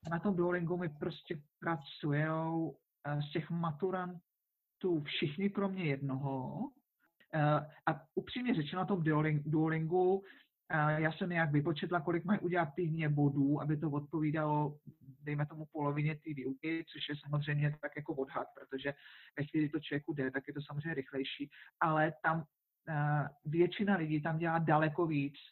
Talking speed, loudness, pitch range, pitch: 140 wpm, -36 LUFS, 150-170 Hz, 155 Hz